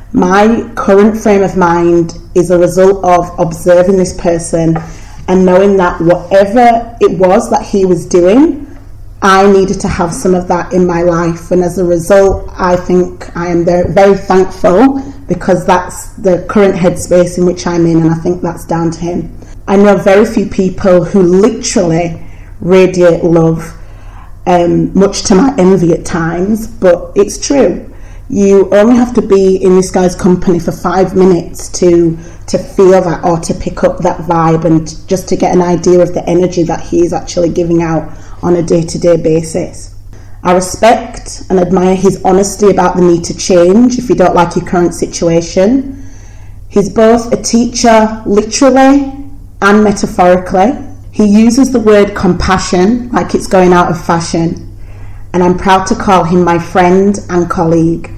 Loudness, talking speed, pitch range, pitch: -9 LUFS, 170 wpm, 170-195 Hz, 180 Hz